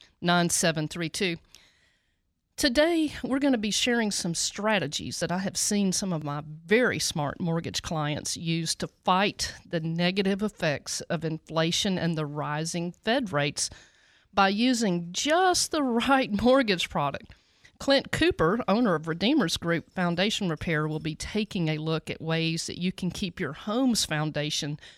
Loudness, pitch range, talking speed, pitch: -27 LUFS, 155-215 Hz, 150 wpm, 175 Hz